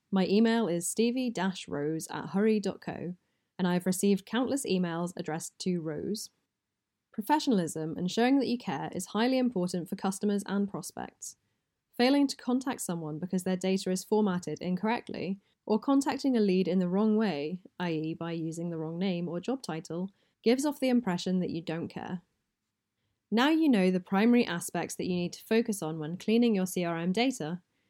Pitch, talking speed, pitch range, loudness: 185 Hz, 175 wpm, 170-225 Hz, -30 LUFS